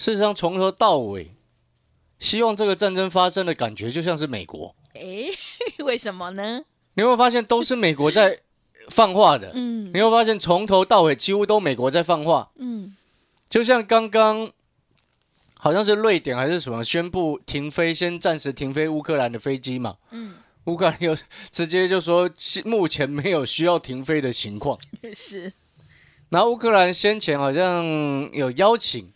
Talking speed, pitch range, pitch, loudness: 250 characters per minute, 150-220 Hz, 180 Hz, -20 LUFS